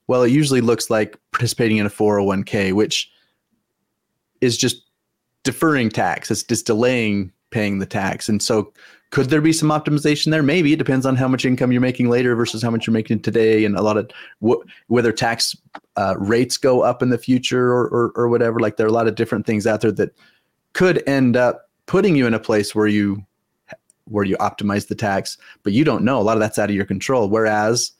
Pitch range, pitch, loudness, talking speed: 105-125 Hz, 115 Hz, -18 LUFS, 215 wpm